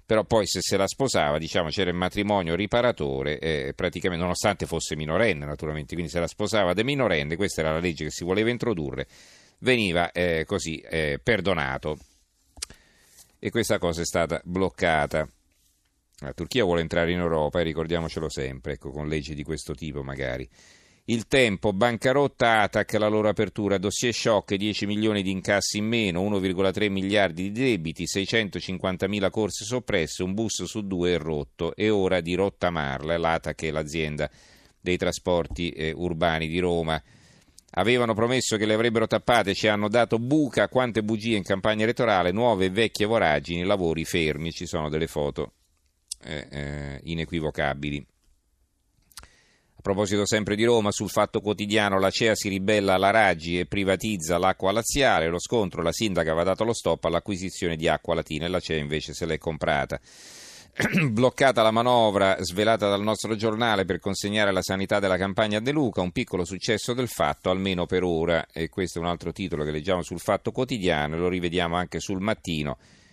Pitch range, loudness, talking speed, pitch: 80-105 Hz, -25 LUFS, 170 wpm, 95 Hz